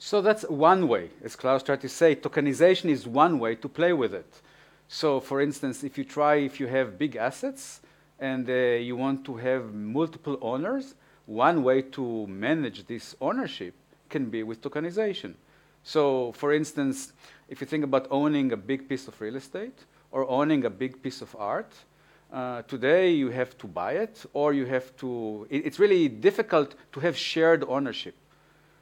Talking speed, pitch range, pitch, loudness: 175 wpm, 130-155 Hz, 140 Hz, -27 LUFS